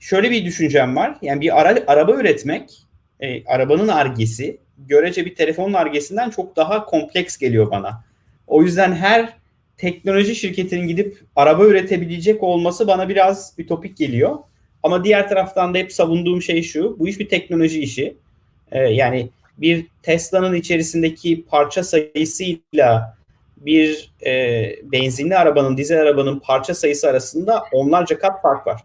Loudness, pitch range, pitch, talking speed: -17 LUFS, 145-190 Hz, 170 Hz, 140 wpm